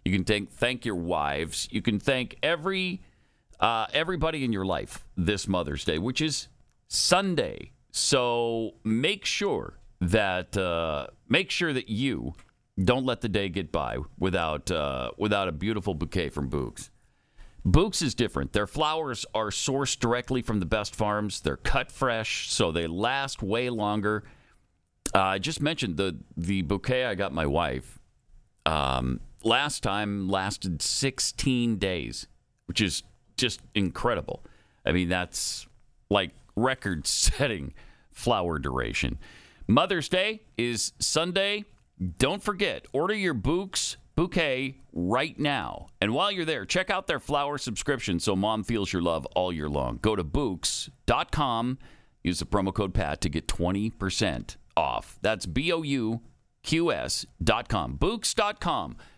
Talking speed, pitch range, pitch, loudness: 145 wpm, 90-130 Hz, 105 Hz, -28 LUFS